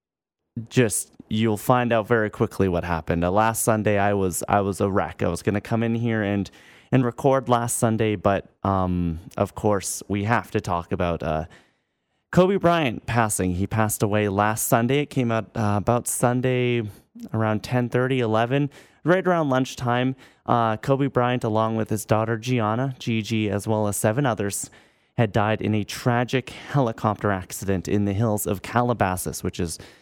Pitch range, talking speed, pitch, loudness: 100-120 Hz, 175 wpm, 110 Hz, -23 LUFS